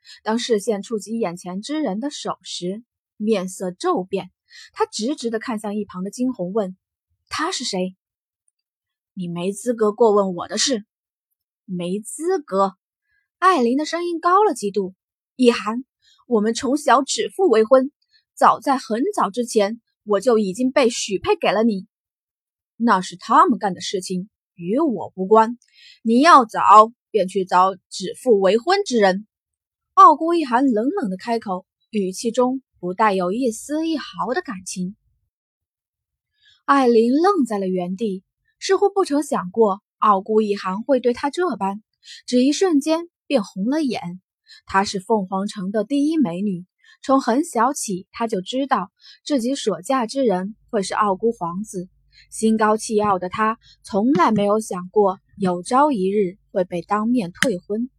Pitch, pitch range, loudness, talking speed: 220 Hz, 195-270 Hz, -20 LUFS, 215 characters per minute